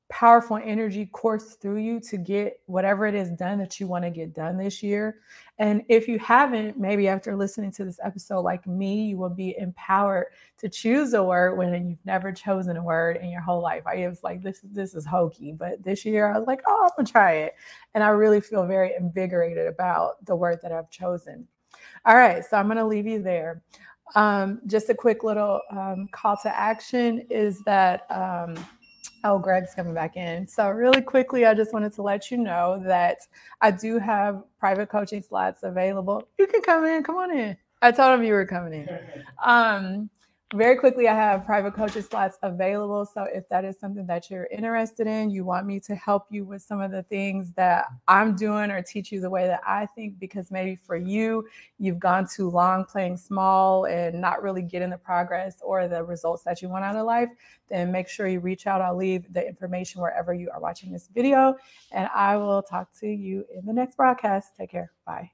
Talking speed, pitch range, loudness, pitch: 215 wpm, 185-215 Hz, -24 LUFS, 200 Hz